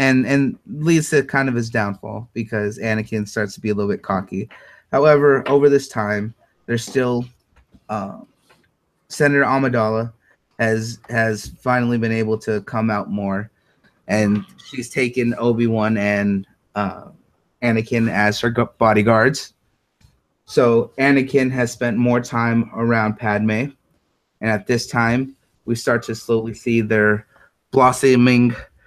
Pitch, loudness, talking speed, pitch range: 115 Hz, -19 LUFS, 135 wpm, 110-125 Hz